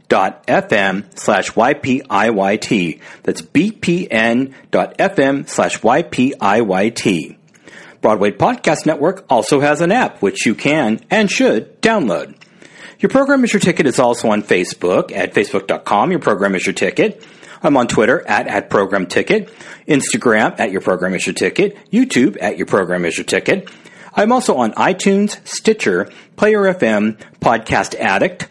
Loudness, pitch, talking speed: -15 LUFS, 175 Hz, 145 wpm